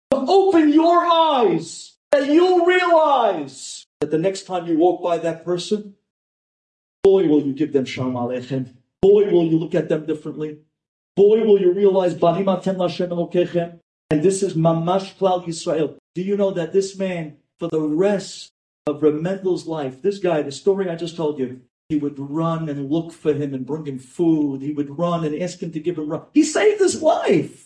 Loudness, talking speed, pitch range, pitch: -20 LUFS, 190 wpm, 155-195 Hz, 175 Hz